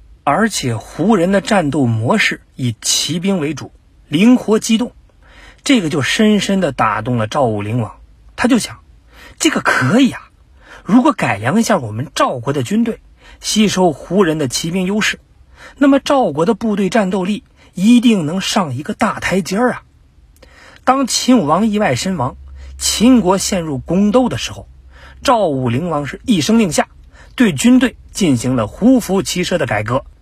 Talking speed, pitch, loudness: 240 characters per minute, 190 Hz, -15 LUFS